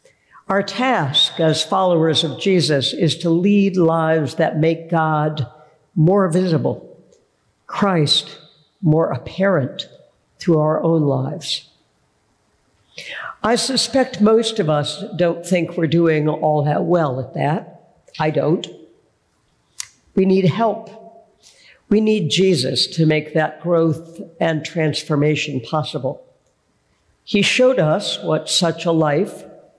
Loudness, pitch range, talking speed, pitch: -18 LUFS, 155-195 Hz, 115 wpm, 165 Hz